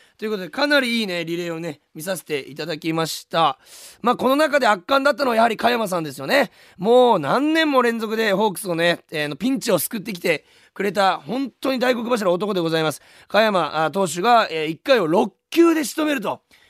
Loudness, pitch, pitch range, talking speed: -20 LUFS, 215 Hz, 170-250 Hz, 400 characters per minute